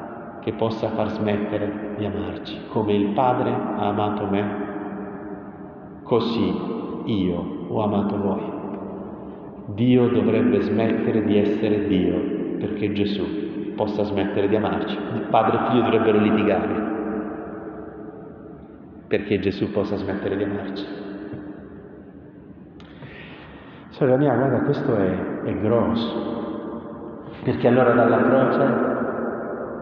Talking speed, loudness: 105 wpm, -22 LUFS